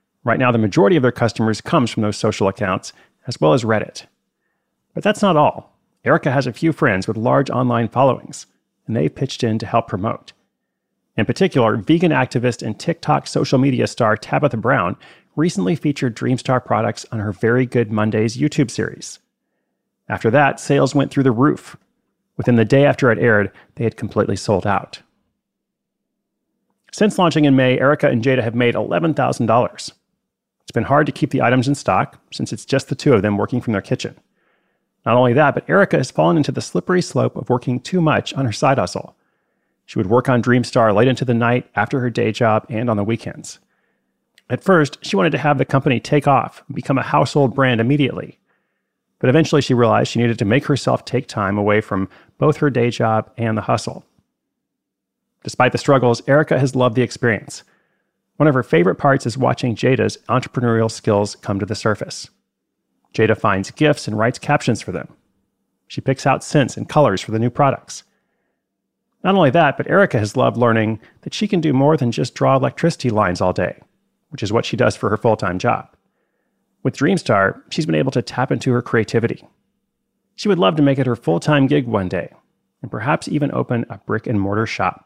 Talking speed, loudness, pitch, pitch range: 195 wpm, -17 LUFS, 125 Hz, 115-145 Hz